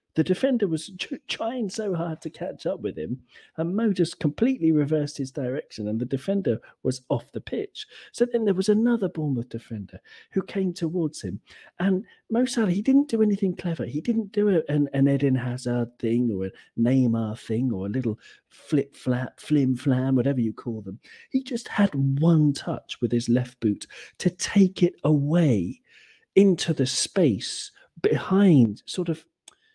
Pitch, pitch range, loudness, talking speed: 155 Hz, 125-195 Hz, -25 LUFS, 175 wpm